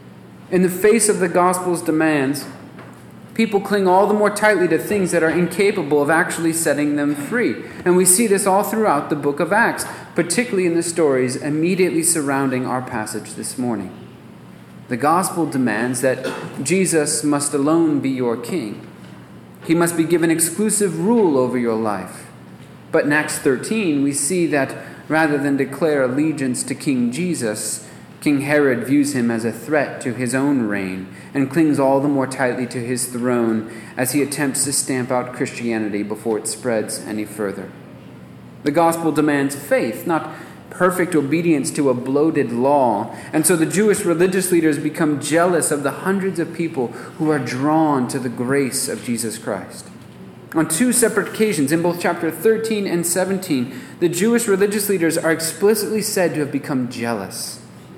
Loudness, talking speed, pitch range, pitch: -19 LUFS, 170 wpm, 125-175 Hz, 150 Hz